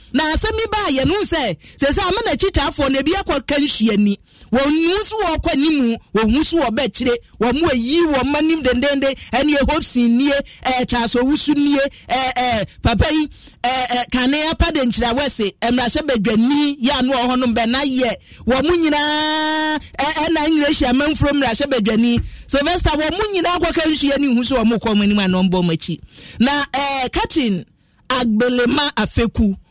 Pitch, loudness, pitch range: 275 Hz, -16 LUFS, 240-305 Hz